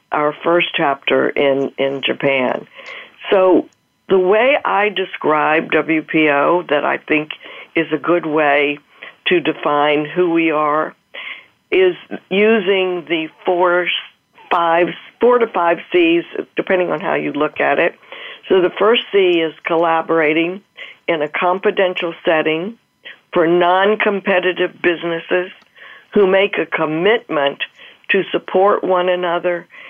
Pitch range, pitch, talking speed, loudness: 155-195 Hz, 175 Hz, 125 wpm, -16 LUFS